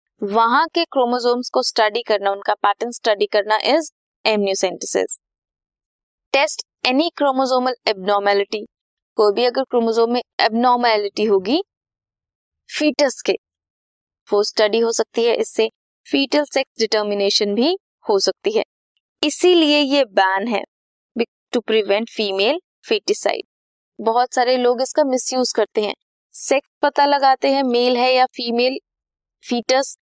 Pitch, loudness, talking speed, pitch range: 245 Hz, -18 LUFS, 120 wpm, 215-275 Hz